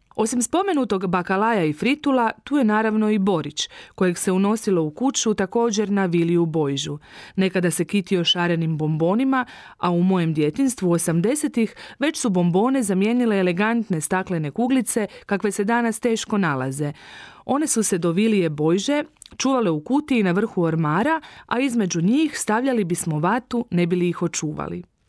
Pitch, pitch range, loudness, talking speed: 200 Hz, 175-235 Hz, -21 LUFS, 150 wpm